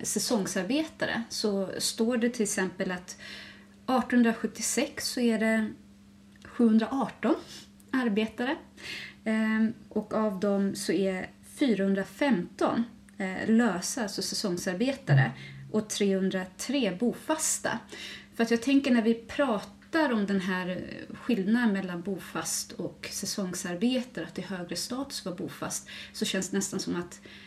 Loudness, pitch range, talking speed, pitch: -29 LUFS, 190-240 Hz, 115 wpm, 215 Hz